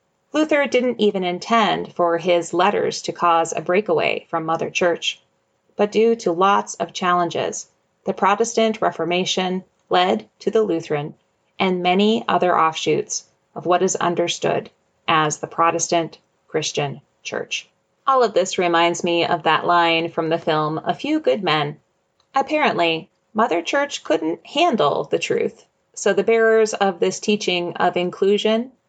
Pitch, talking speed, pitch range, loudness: 180 Hz, 145 wpm, 170-225 Hz, -20 LUFS